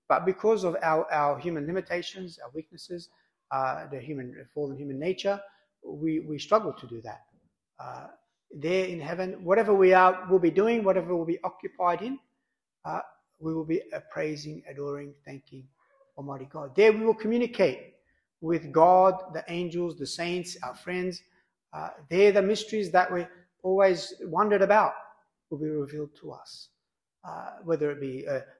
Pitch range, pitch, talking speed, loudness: 150-195 Hz, 175 Hz, 160 wpm, -27 LUFS